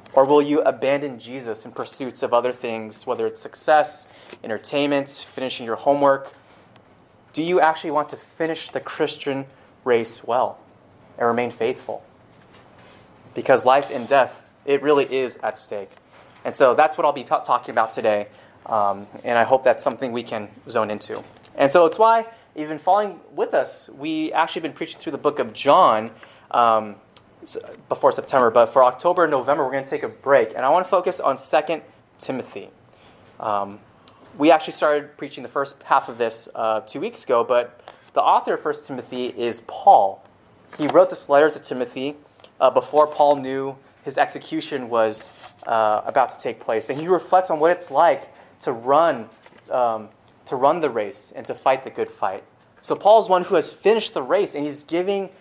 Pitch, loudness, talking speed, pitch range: 140 Hz, -21 LUFS, 185 wpm, 120-160 Hz